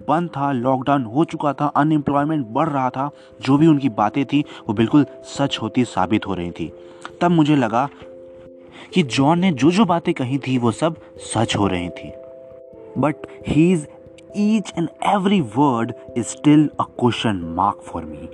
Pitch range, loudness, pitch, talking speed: 115-155 Hz, -19 LUFS, 140 Hz, 175 wpm